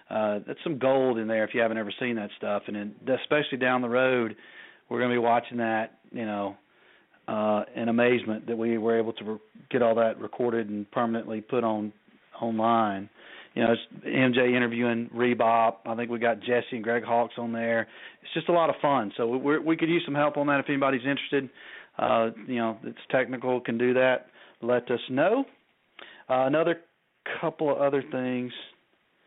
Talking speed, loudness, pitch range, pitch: 195 wpm, -27 LUFS, 115-130 Hz, 120 Hz